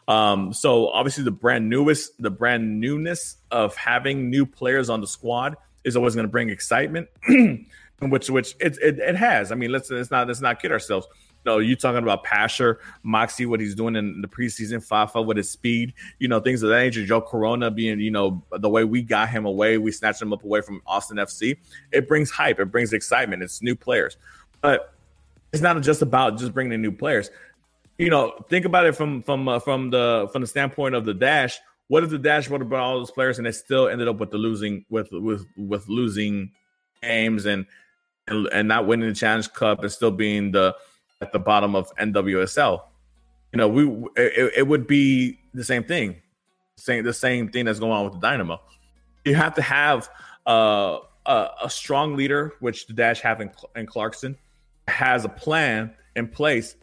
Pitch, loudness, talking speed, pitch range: 115 Hz, -22 LUFS, 205 wpm, 105-135 Hz